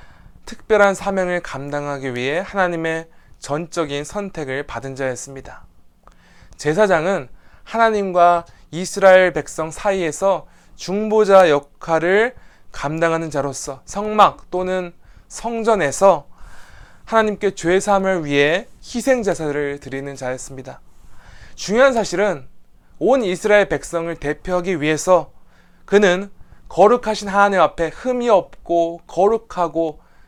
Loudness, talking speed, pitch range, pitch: -18 LUFS, 260 characters per minute, 145-200 Hz, 170 Hz